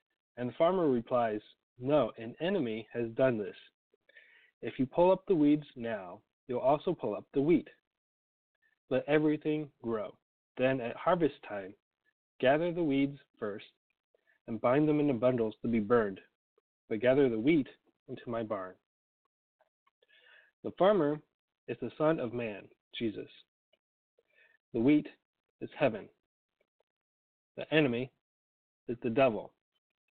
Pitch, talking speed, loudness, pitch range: 135 Hz, 130 wpm, -31 LUFS, 115-160 Hz